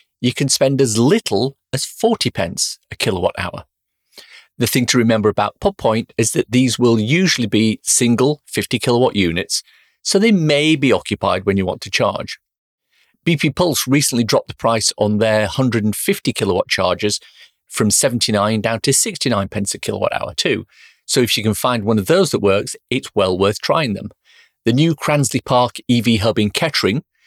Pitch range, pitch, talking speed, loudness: 105-135 Hz, 120 Hz, 180 wpm, -17 LUFS